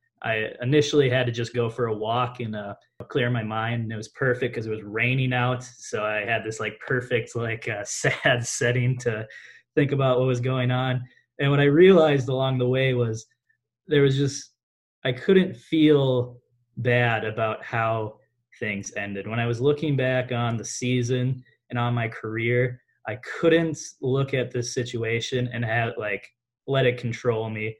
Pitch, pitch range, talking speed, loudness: 120 Hz, 115-130 Hz, 180 wpm, -24 LUFS